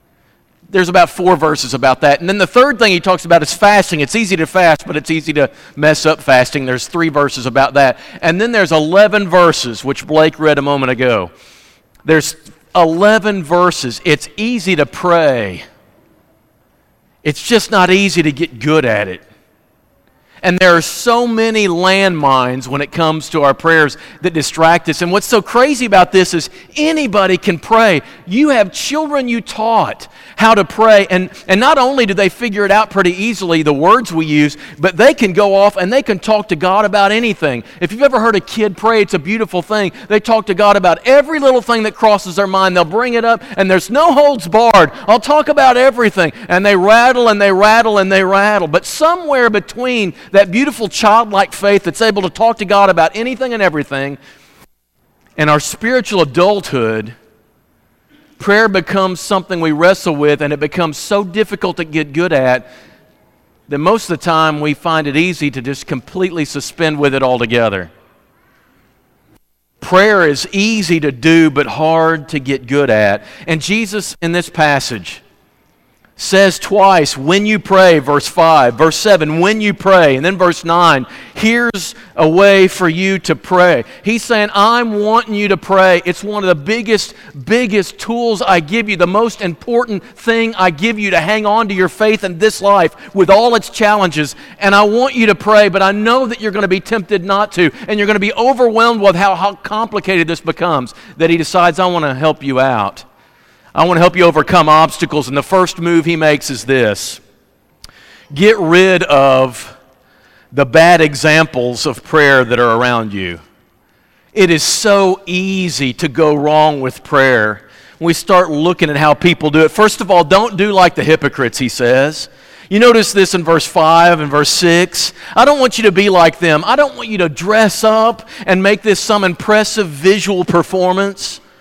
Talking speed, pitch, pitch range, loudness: 190 wpm, 185 Hz, 155-210 Hz, -11 LUFS